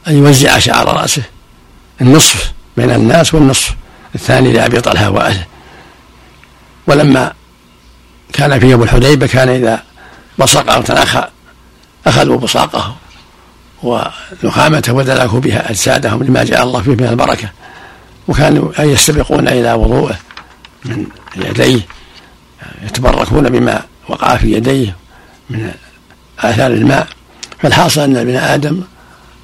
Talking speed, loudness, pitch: 110 wpm, -10 LUFS, 125 Hz